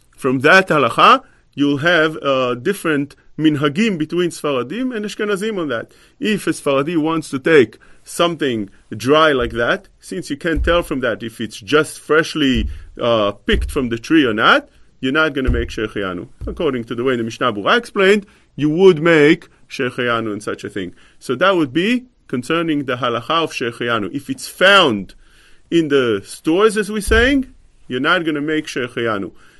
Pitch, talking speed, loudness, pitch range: 150 Hz, 175 wpm, -17 LUFS, 120-170 Hz